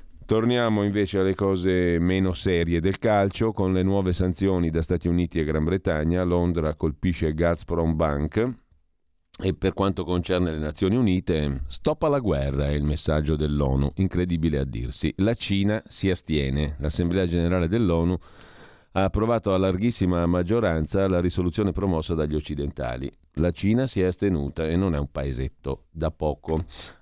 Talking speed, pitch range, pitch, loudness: 150 wpm, 75-95 Hz, 90 Hz, -24 LUFS